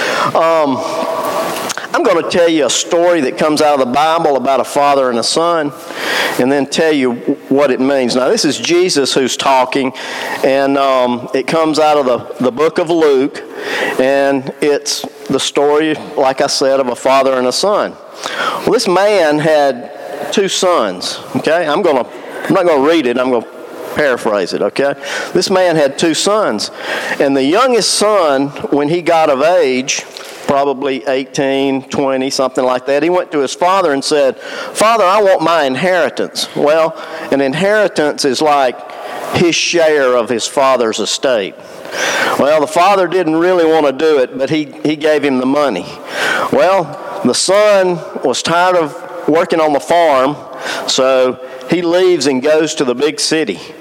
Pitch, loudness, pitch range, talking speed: 150 Hz, -13 LUFS, 135-175 Hz, 175 wpm